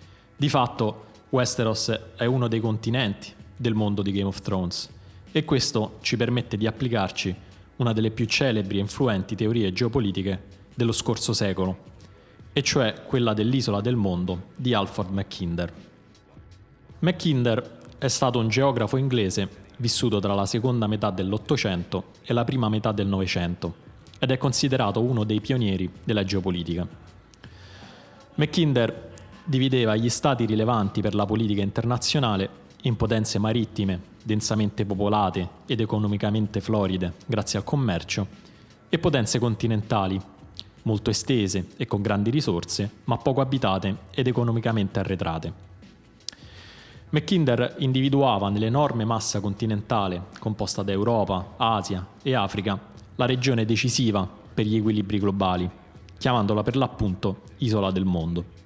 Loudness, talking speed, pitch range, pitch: -25 LUFS, 125 wpm, 100-120 Hz, 110 Hz